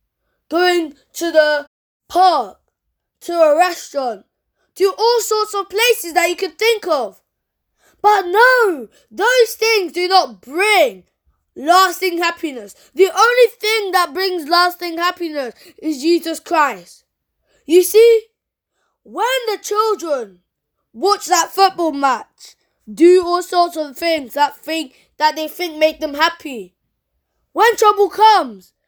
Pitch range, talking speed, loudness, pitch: 310-405 Hz, 125 wpm, -15 LUFS, 350 Hz